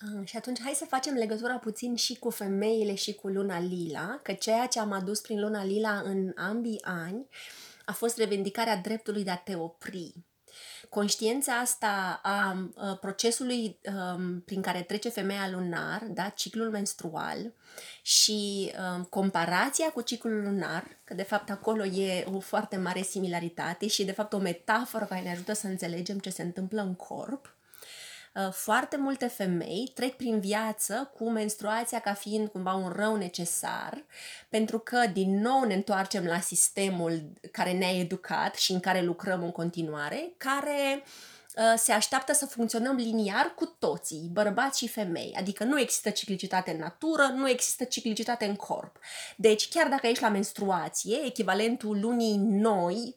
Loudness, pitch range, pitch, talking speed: -30 LUFS, 190-230 Hz, 210 Hz, 155 wpm